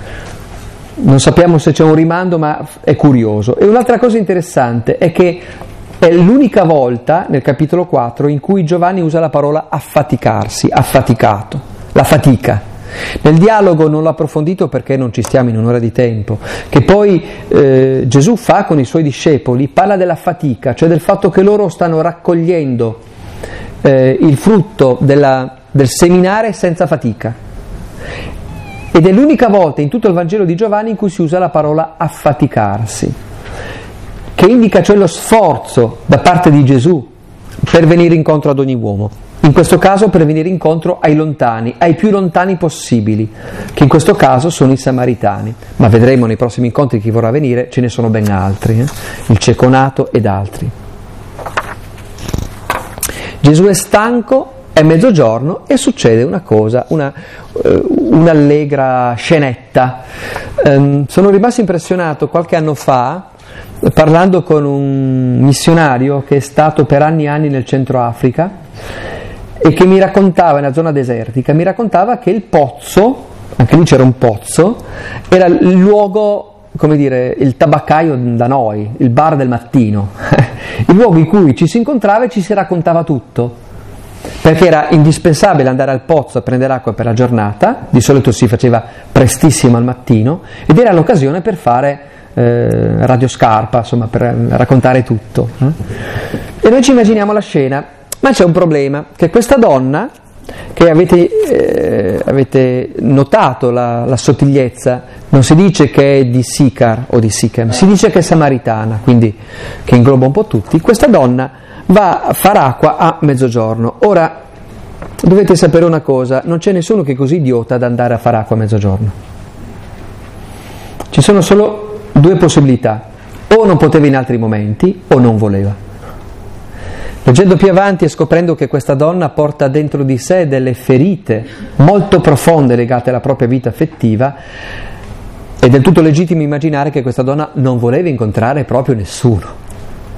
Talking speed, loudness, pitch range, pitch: 155 wpm, -10 LUFS, 120-170 Hz, 140 Hz